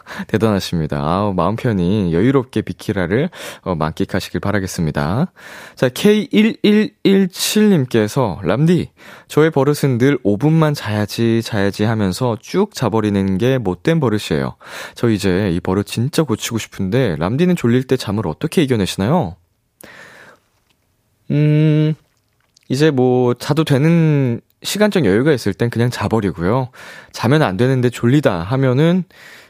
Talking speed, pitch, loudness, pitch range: 275 characters per minute, 125 Hz, -16 LUFS, 100-150 Hz